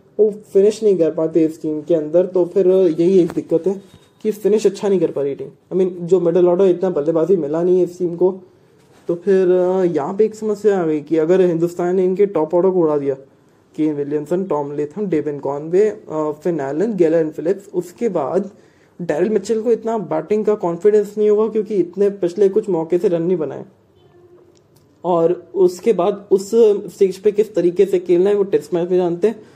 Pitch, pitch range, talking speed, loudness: 180 Hz, 165-205 Hz, 195 wpm, -17 LUFS